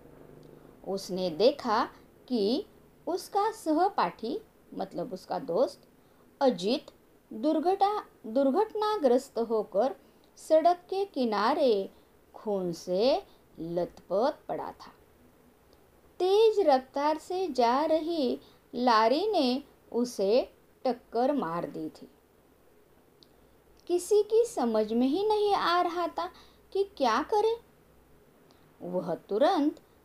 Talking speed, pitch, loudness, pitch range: 90 wpm, 285 Hz, -29 LUFS, 235-370 Hz